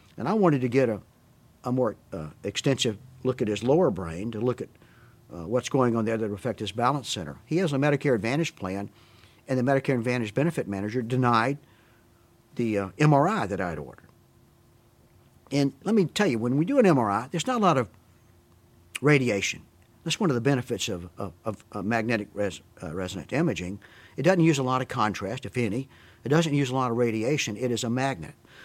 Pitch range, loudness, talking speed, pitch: 105-140 Hz, -26 LUFS, 205 wpm, 120 Hz